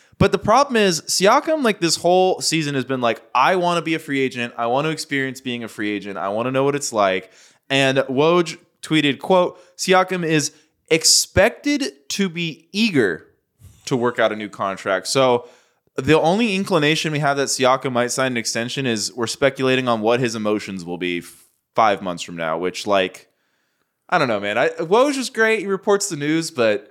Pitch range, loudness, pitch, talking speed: 115-175 Hz, -19 LUFS, 140 Hz, 205 wpm